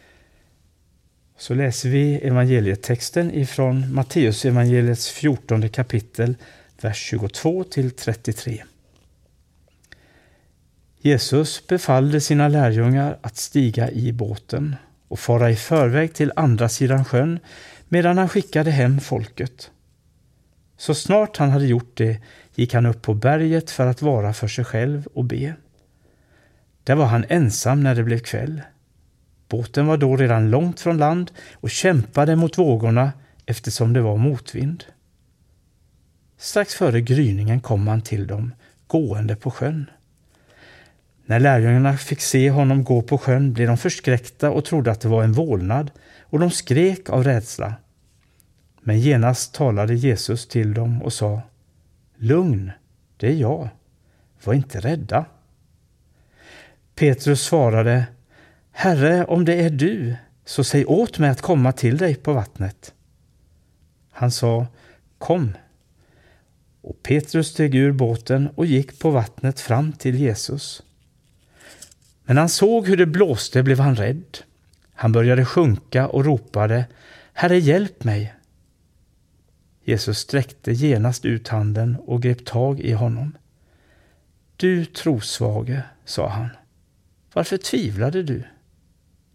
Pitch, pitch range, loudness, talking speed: 125 Hz, 110-145 Hz, -20 LUFS, 125 wpm